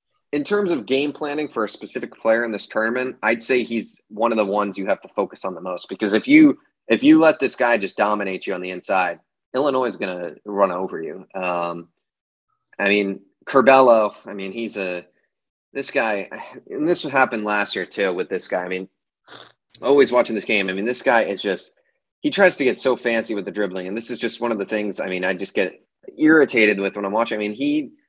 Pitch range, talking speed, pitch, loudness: 100-135 Hz, 230 wpm, 110 Hz, -20 LUFS